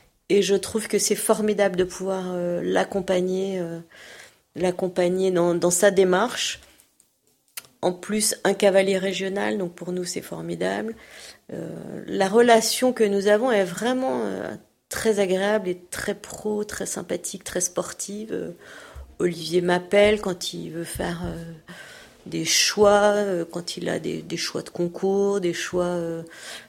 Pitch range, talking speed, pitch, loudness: 175-205 Hz, 150 wpm, 190 Hz, -23 LUFS